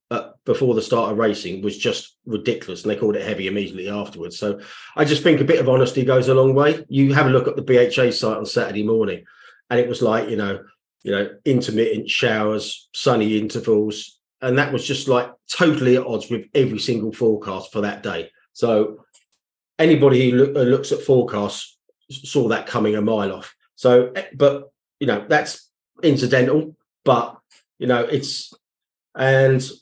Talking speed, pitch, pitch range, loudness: 180 wpm, 125 Hz, 105-135 Hz, -19 LUFS